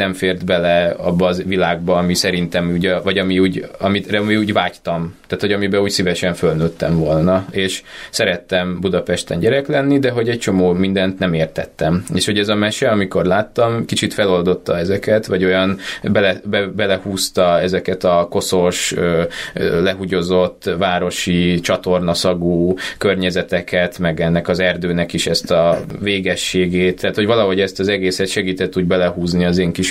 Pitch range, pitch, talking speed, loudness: 90-95 Hz, 90 Hz, 155 wpm, -17 LUFS